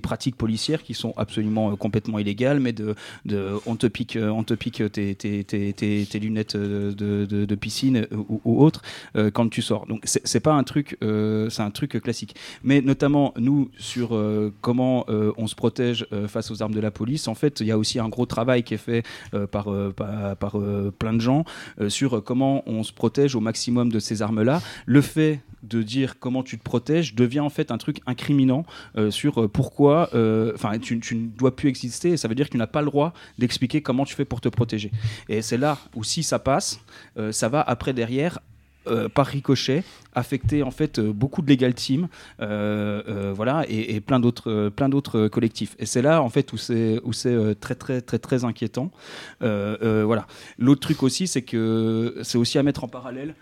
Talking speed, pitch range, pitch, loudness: 225 wpm, 110-135 Hz, 115 Hz, -24 LUFS